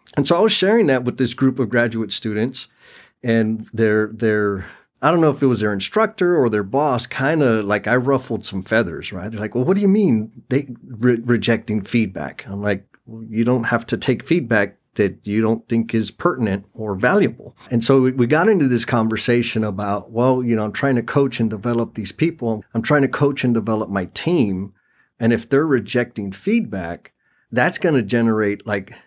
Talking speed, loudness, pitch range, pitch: 205 wpm, -19 LUFS, 110-130 Hz, 115 Hz